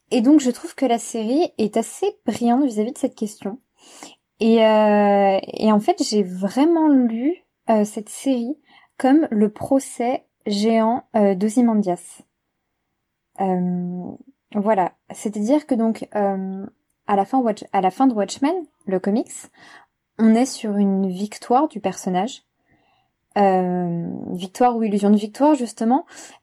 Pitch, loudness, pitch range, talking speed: 225 Hz, -20 LUFS, 205-265 Hz, 140 wpm